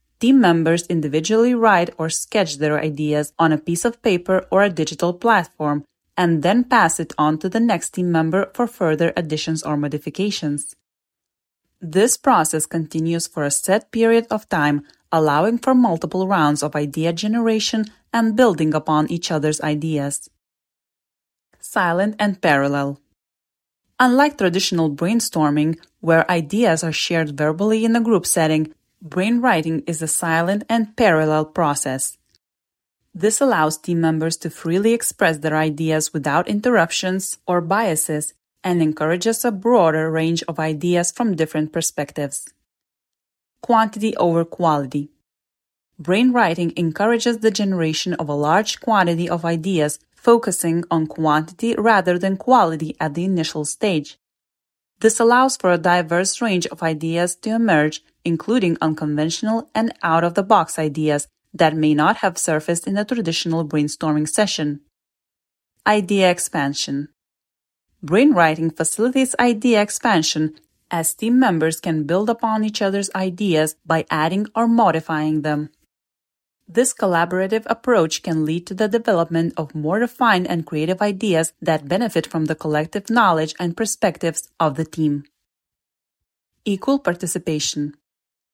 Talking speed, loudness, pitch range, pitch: 135 wpm, -19 LUFS, 155-210 Hz, 170 Hz